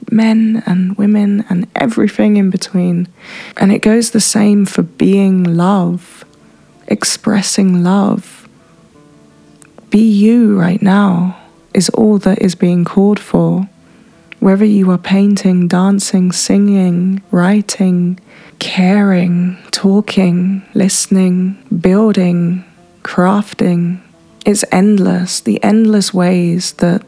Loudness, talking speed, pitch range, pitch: -12 LUFS, 100 wpm, 180-210 Hz, 195 Hz